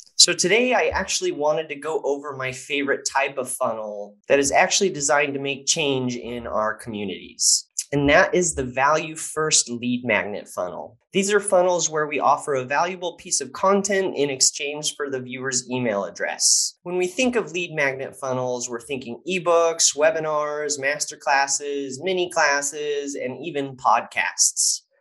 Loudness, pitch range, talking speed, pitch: -21 LUFS, 130-170 Hz, 165 wpm, 145 Hz